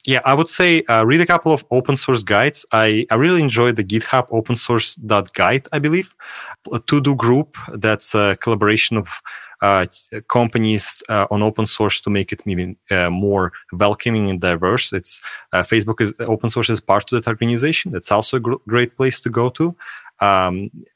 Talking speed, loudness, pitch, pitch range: 190 wpm, -17 LUFS, 115 Hz, 105-130 Hz